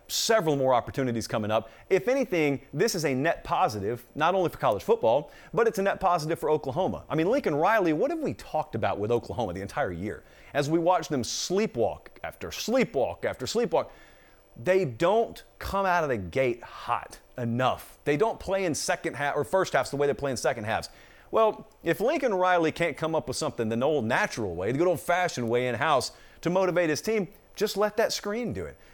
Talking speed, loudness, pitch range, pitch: 205 wpm, -27 LUFS, 135-190 Hz, 165 Hz